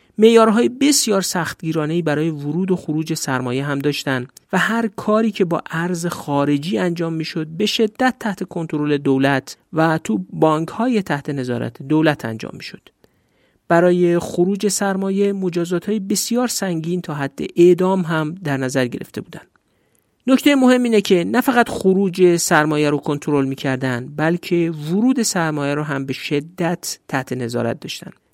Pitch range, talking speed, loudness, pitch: 145-195 Hz, 150 wpm, -18 LUFS, 170 Hz